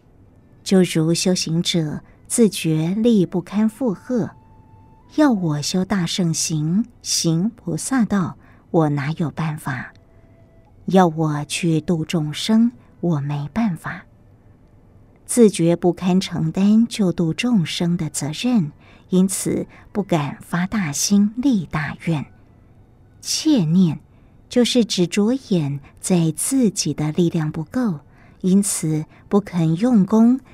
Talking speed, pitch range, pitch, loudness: 160 characters per minute, 145-200 Hz, 170 Hz, -20 LUFS